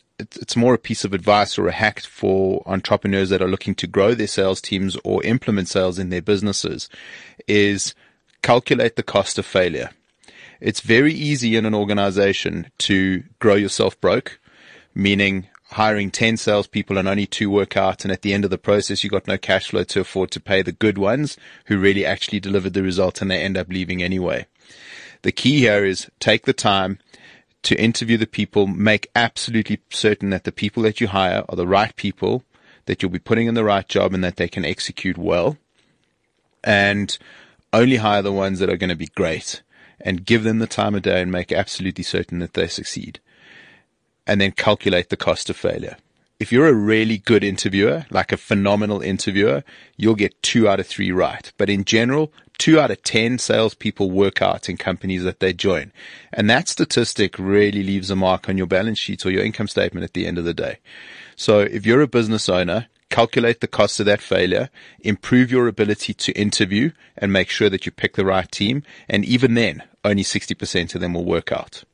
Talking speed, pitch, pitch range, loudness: 200 wpm, 100 Hz, 95-110 Hz, -19 LUFS